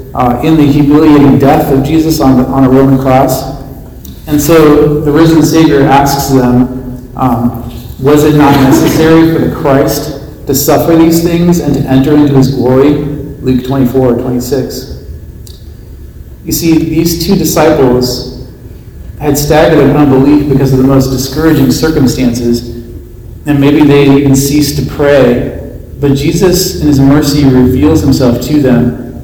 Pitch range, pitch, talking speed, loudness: 130-150 Hz, 140 Hz, 150 wpm, -7 LUFS